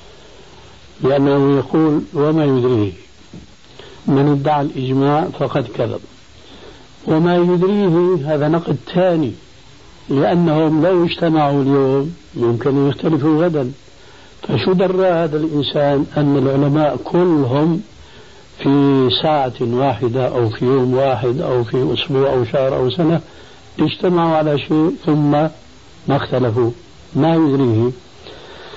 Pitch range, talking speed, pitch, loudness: 130-160 Hz, 110 wpm, 145 Hz, -16 LUFS